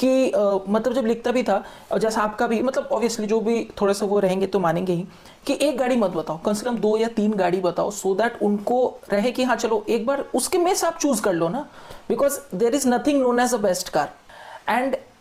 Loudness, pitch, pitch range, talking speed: -22 LUFS, 230 Hz, 200-255 Hz, 250 wpm